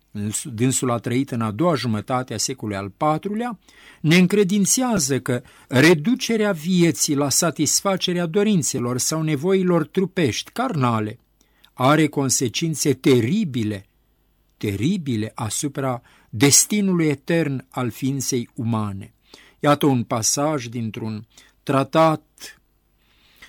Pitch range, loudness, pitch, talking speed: 120-170 Hz, -20 LUFS, 140 Hz, 95 wpm